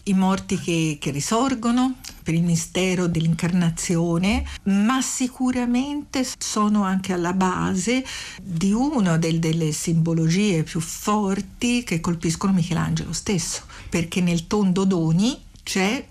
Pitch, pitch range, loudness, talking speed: 185 Hz, 170-210 Hz, -22 LUFS, 115 wpm